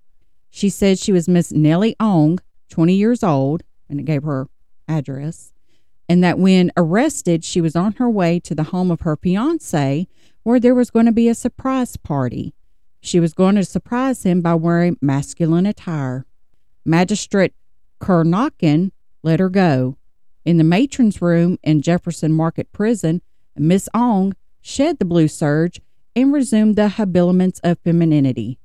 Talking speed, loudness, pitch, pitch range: 155 wpm, -17 LUFS, 175 Hz, 155-205 Hz